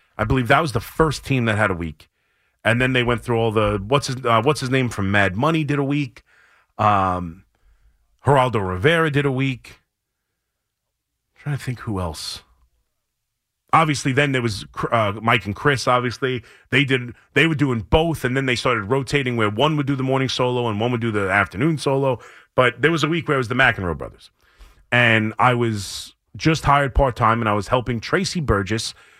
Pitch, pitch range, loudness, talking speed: 125 Hz, 105-140 Hz, -20 LUFS, 205 wpm